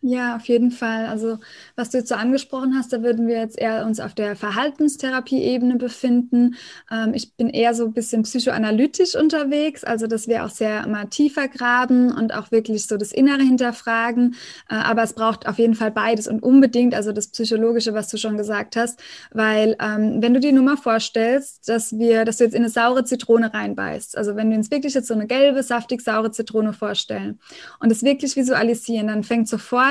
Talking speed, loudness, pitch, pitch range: 205 wpm, -20 LUFS, 230 Hz, 220-255 Hz